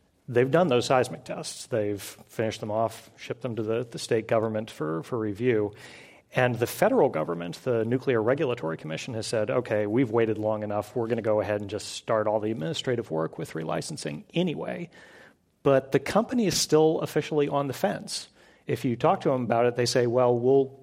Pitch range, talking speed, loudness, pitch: 105-135 Hz, 200 wpm, -27 LUFS, 115 Hz